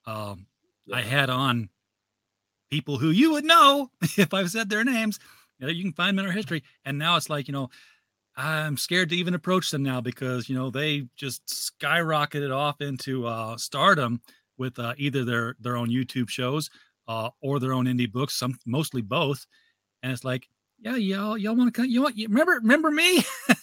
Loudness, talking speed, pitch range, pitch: -25 LUFS, 200 wpm, 125-190 Hz, 140 Hz